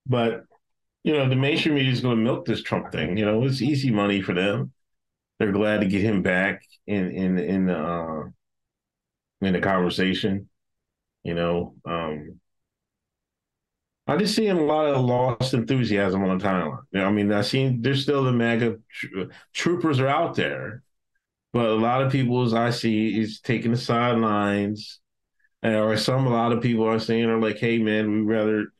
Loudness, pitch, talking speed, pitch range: -23 LUFS, 110 Hz, 185 wpm, 95-125 Hz